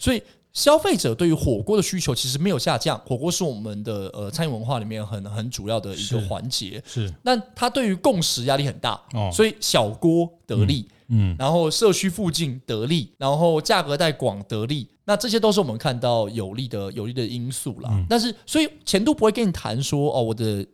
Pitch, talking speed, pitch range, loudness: 135 Hz, 310 characters per minute, 110-180 Hz, -23 LUFS